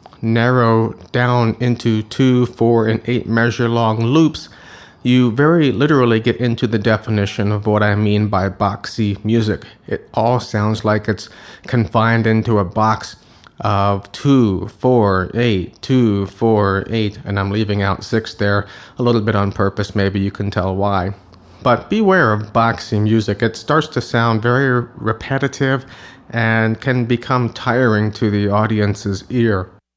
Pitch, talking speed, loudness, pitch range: 110 Hz, 150 wpm, -17 LUFS, 105-120 Hz